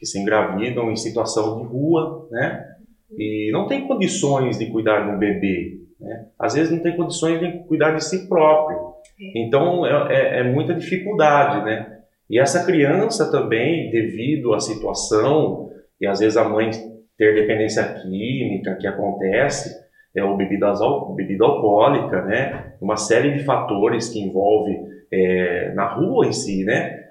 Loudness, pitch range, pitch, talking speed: -20 LUFS, 105-160 Hz, 115 Hz, 155 wpm